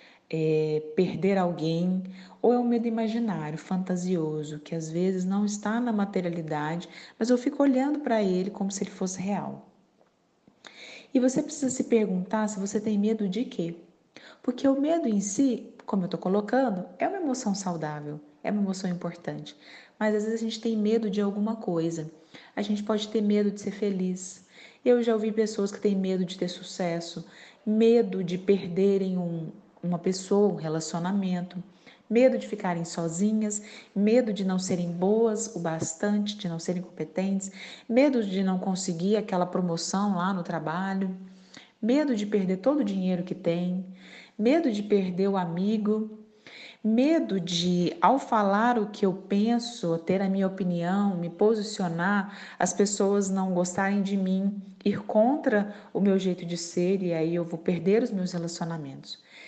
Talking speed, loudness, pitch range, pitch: 165 wpm, -27 LUFS, 180-220 Hz, 195 Hz